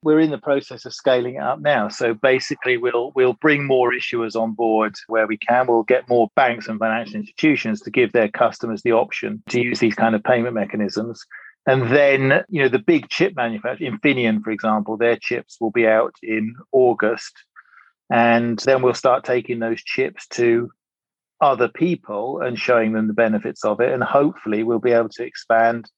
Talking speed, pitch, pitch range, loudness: 190 wpm, 120 Hz, 115-130 Hz, -19 LUFS